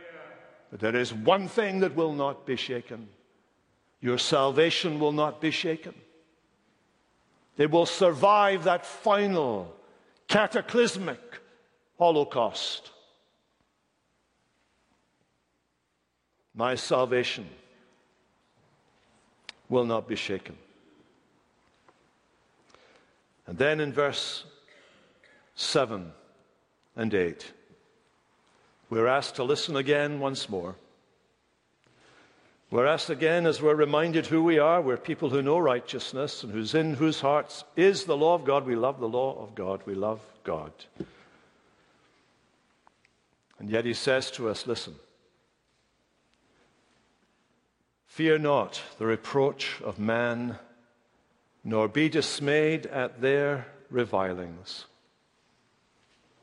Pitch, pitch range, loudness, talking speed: 140 Hz, 115-160 Hz, -27 LUFS, 100 wpm